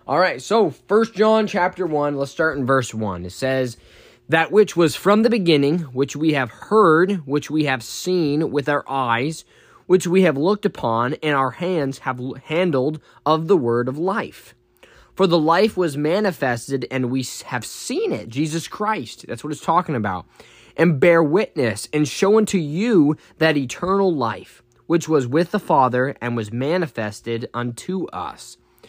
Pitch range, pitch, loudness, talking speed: 130-180 Hz, 150 Hz, -20 LUFS, 170 wpm